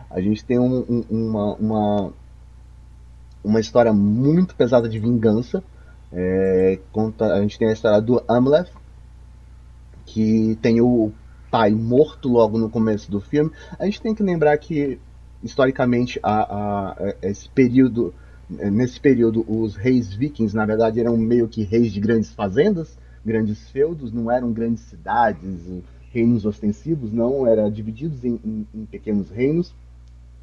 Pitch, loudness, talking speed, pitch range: 110 Hz, -20 LUFS, 145 wpm, 95-120 Hz